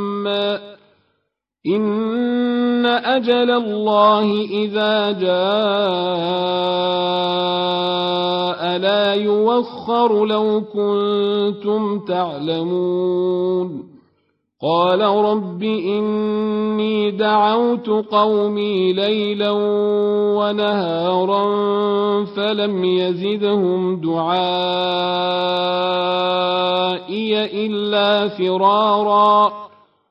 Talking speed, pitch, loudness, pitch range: 45 wpm, 205 Hz, -18 LUFS, 180-210 Hz